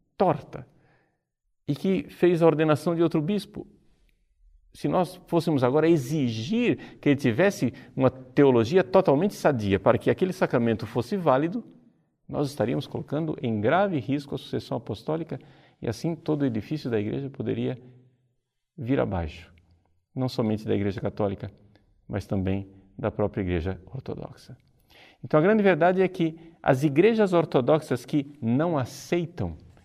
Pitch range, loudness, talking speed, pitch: 110-160 Hz, -25 LUFS, 140 wpm, 130 Hz